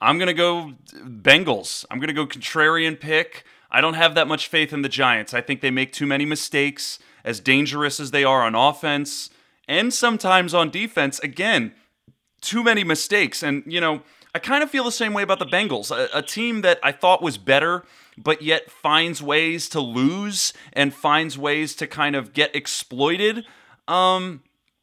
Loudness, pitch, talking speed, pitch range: -20 LUFS, 155 Hz, 190 wpm, 145-185 Hz